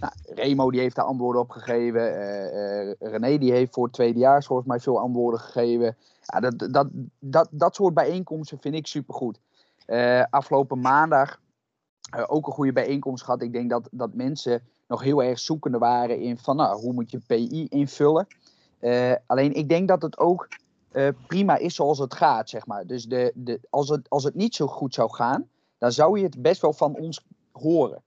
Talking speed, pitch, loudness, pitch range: 200 wpm, 135 Hz, -24 LUFS, 120-150 Hz